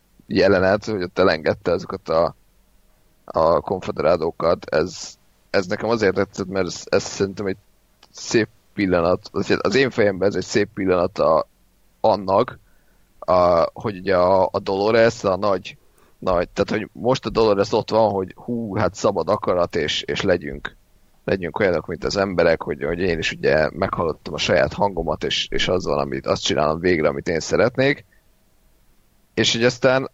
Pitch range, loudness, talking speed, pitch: 95-115 Hz, -20 LUFS, 155 wpm, 100 Hz